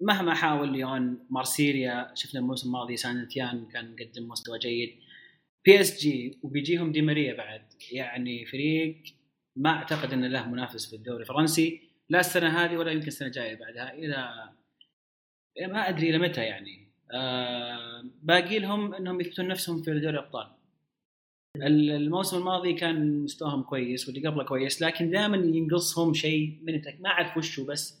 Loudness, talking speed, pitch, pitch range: -28 LUFS, 145 wpm, 145 Hz, 125-165 Hz